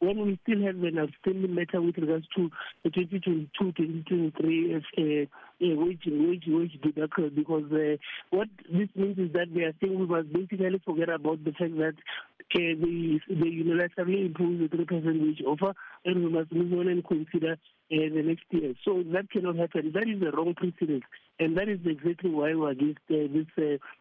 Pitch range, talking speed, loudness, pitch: 160-180 Hz, 205 wpm, -29 LUFS, 170 Hz